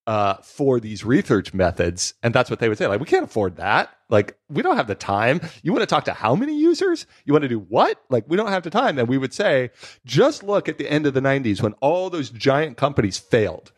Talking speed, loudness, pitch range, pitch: 255 wpm, -21 LUFS, 115-180 Hz, 135 Hz